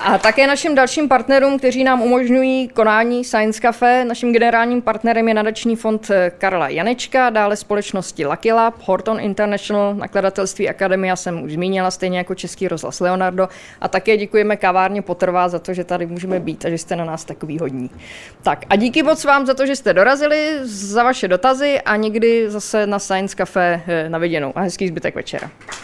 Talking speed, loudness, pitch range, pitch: 180 wpm, -17 LUFS, 185-235 Hz, 205 Hz